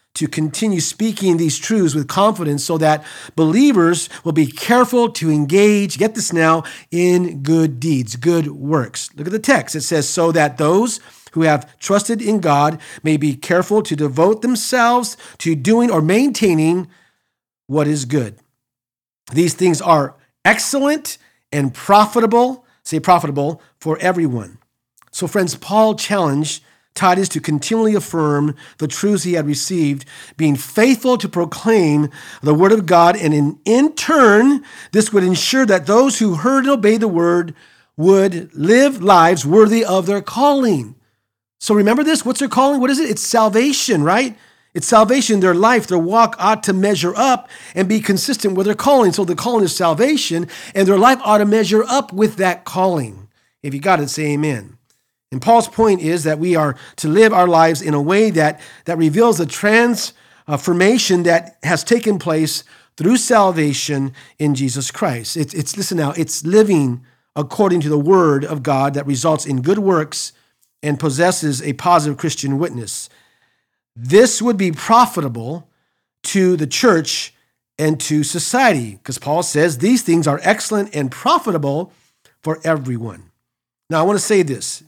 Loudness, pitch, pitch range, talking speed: -15 LUFS, 170 Hz, 150-215 Hz, 165 wpm